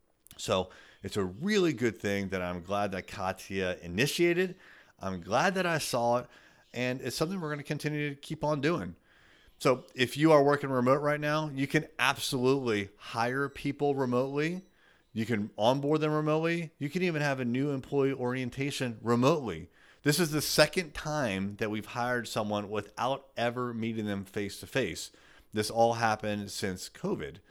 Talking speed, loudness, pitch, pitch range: 170 wpm, -30 LUFS, 130 Hz, 110-150 Hz